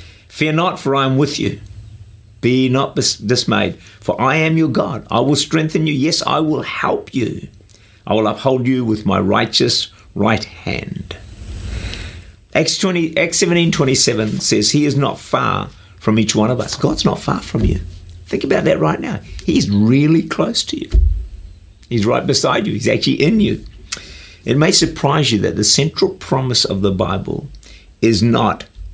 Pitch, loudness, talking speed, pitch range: 110 Hz, -16 LUFS, 175 wpm, 100-140 Hz